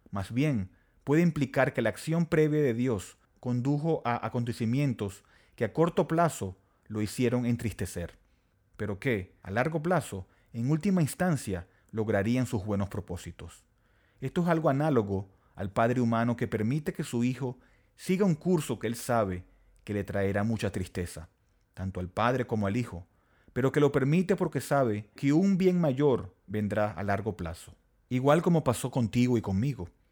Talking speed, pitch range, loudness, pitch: 160 wpm, 100-140 Hz, -29 LUFS, 115 Hz